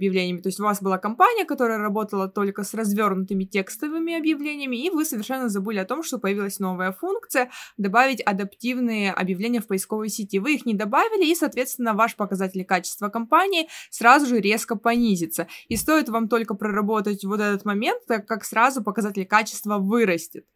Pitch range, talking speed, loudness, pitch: 200-250 Hz, 170 wpm, -23 LUFS, 220 Hz